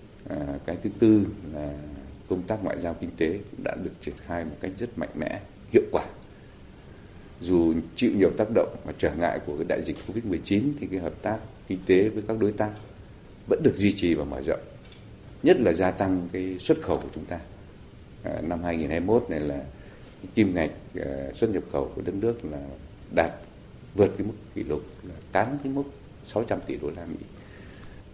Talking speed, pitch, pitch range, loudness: 195 wpm, 90 Hz, 80-100 Hz, -27 LUFS